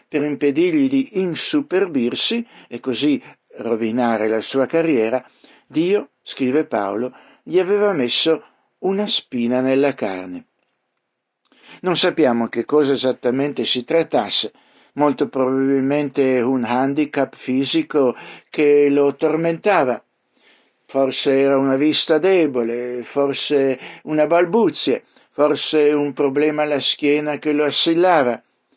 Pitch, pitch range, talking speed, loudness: 145 Hz, 130-165 Hz, 105 wpm, -19 LUFS